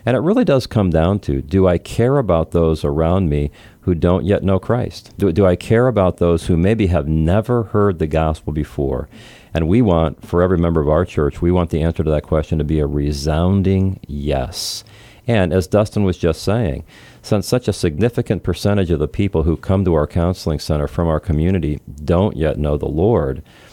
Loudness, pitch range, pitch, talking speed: -17 LUFS, 80-100 Hz, 90 Hz, 205 wpm